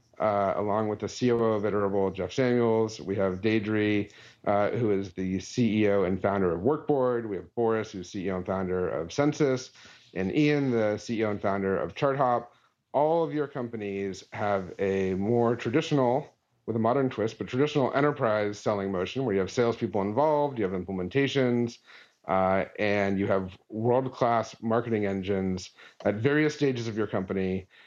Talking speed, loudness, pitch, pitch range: 165 wpm, -28 LUFS, 105 Hz, 100-125 Hz